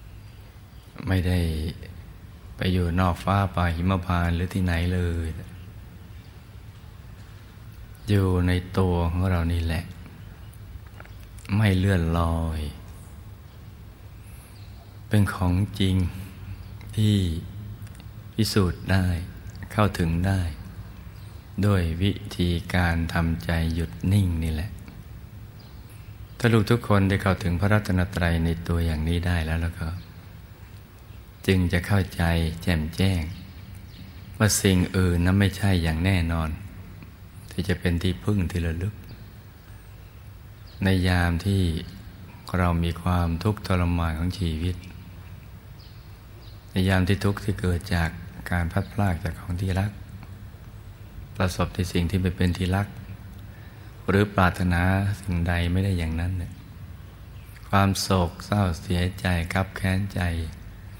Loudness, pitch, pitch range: -25 LUFS, 95 Hz, 90-100 Hz